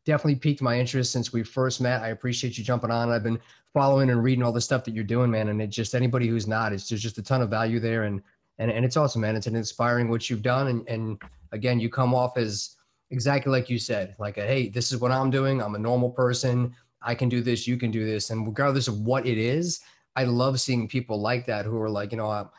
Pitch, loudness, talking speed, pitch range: 120 Hz, -26 LUFS, 270 wpm, 115-130 Hz